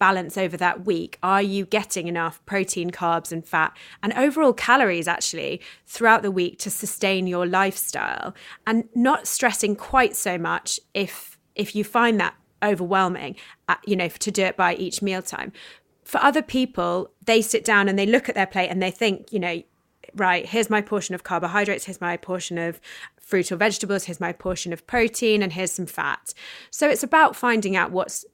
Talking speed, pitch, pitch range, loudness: 190 wpm, 195 Hz, 180-225 Hz, -22 LUFS